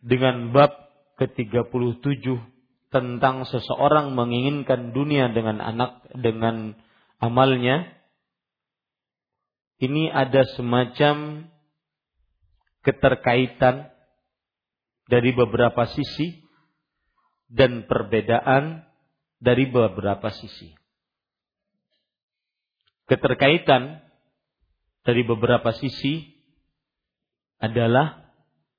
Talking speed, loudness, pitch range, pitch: 60 wpm, -22 LUFS, 120-140 Hz, 125 Hz